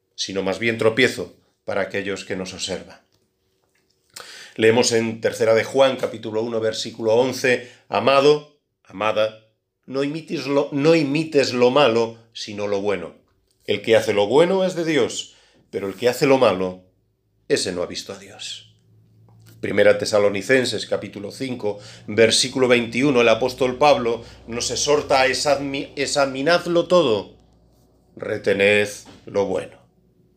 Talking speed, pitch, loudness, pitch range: 135 wpm, 115 Hz, -20 LUFS, 105-135 Hz